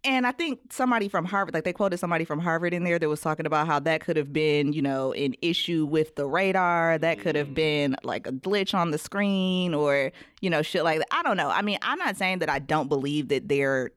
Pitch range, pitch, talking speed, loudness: 150-185 Hz, 160 Hz, 260 wpm, -26 LUFS